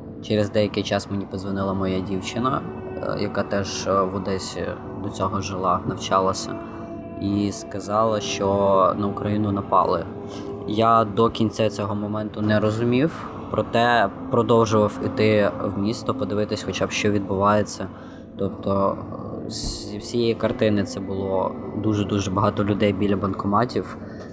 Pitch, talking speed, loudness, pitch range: 100 Hz, 125 wpm, -23 LUFS, 100-110 Hz